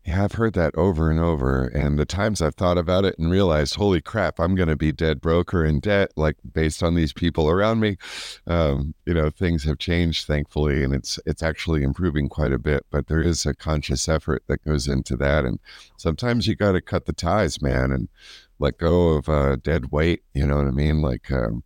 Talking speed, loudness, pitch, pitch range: 220 wpm, -22 LUFS, 80 Hz, 75-85 Hz